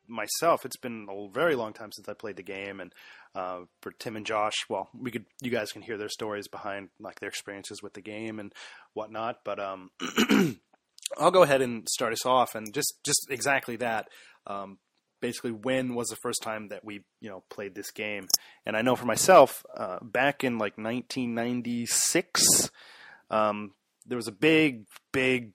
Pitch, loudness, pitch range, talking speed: 110 Hz, -27 LUFS, 100-125 Hz, 190 wpm